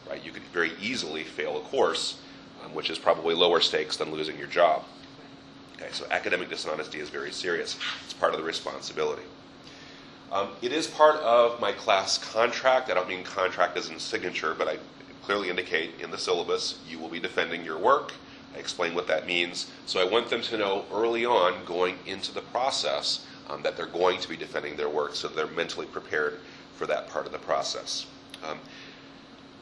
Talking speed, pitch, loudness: 190 wpm, 155 Hz, -28 LUFS